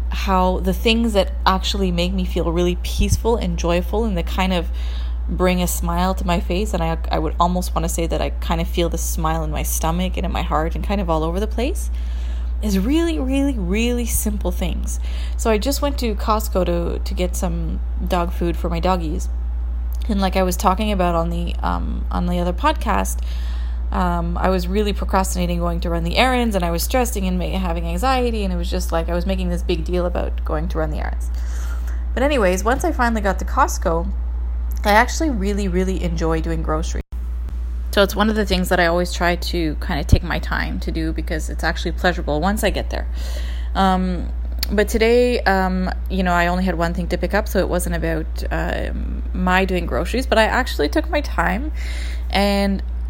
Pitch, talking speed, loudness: 175 Hz, 215 wpm, -20 LUFS